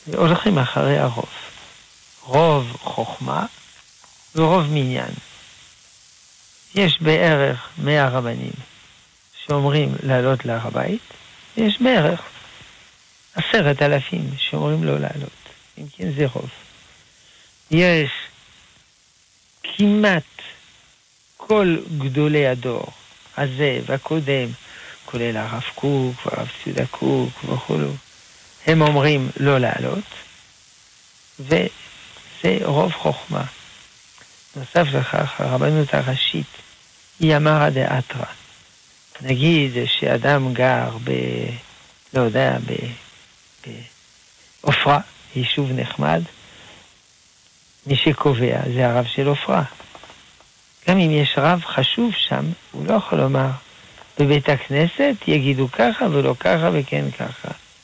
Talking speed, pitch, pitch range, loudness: 90 wpm, 140 Hz, 125-155 Hz, -20 LUFS